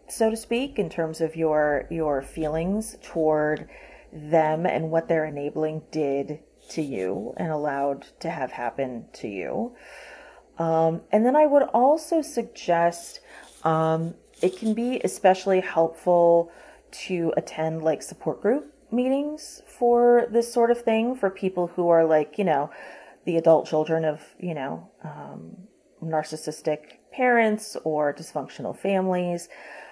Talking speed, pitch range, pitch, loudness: 135 wpm, 155-210 Hz, 165 Hz, -24 LUFS